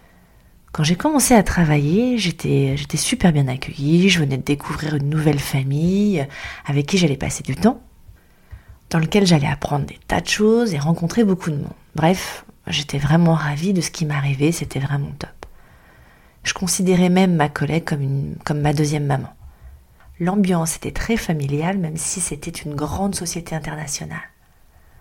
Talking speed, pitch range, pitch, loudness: 165 wpm, 145-180 Hz, 155 Hz, -19 LUFS